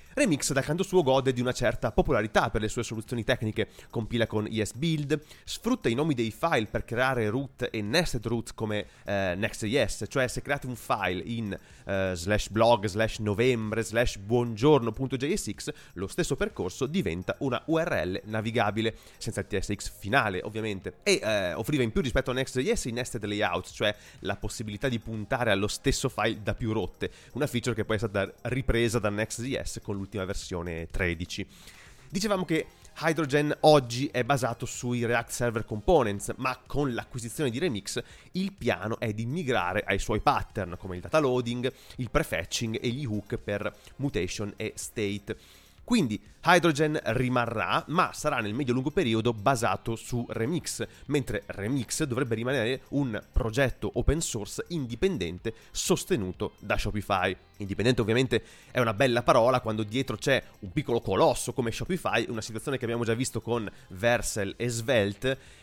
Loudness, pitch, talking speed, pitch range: -29 LUFS, 115 Hz, 160 wpm, 105-130 Hz